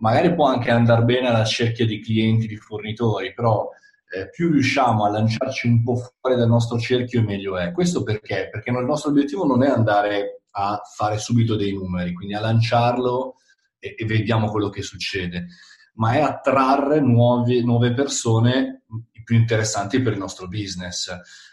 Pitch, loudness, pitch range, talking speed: 115 Hz, -21 LUFS, 105-125 Hz, 165 wpm